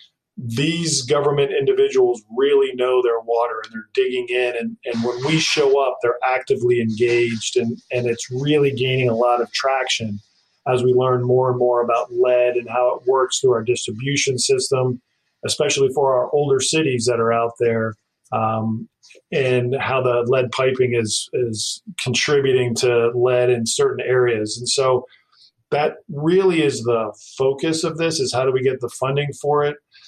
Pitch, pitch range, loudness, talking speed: 125 Hz, 120-145 Hz, -19 LUFS, 170 wpm